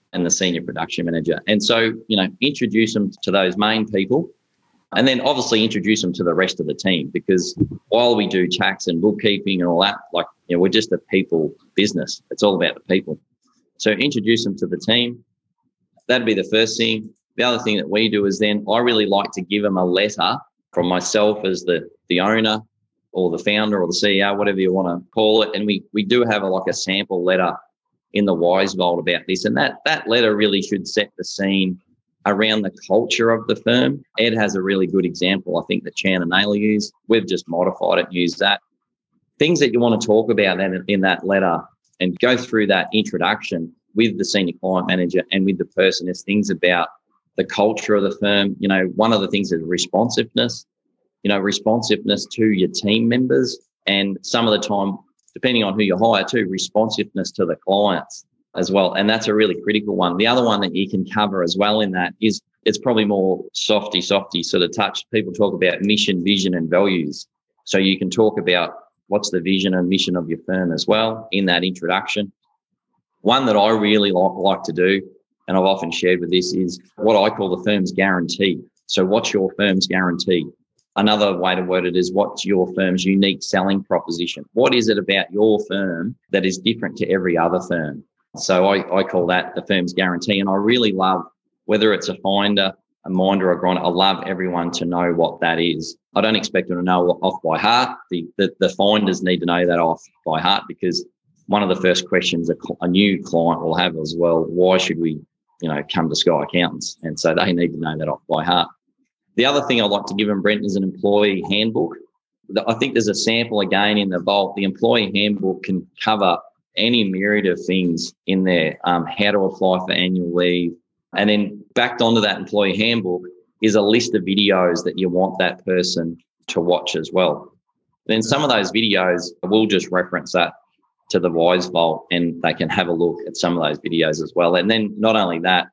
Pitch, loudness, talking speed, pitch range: 95 Hz, -19 LUFS, 215 wpm, 90-105 Hz